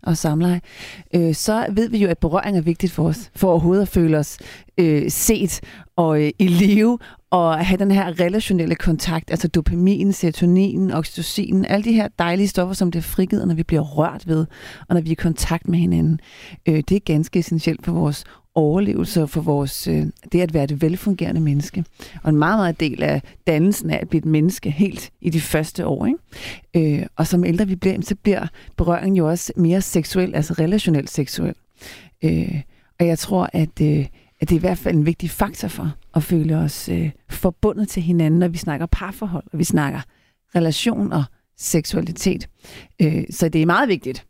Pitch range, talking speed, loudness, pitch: 155-190 Hz, 195 wpm, -20 LUFS, 170 Hz